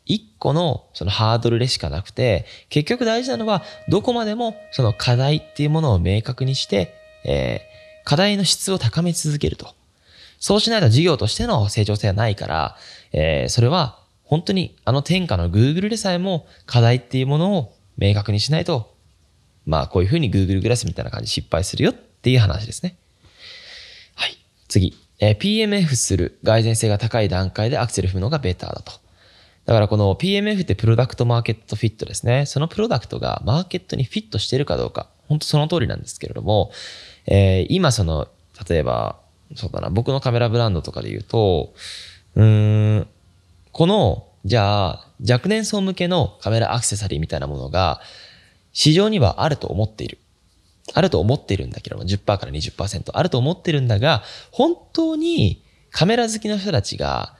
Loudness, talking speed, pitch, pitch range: -20 LUFS, 375 characters per minute, 120 Hz, 100-165 Hz